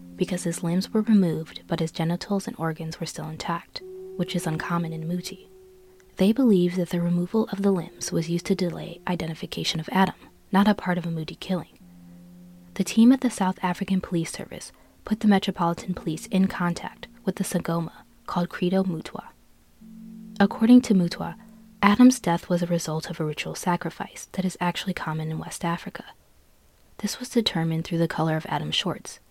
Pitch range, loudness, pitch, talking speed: 165-195 Hz, -25 LUFS, 180 Hz, 180 wpm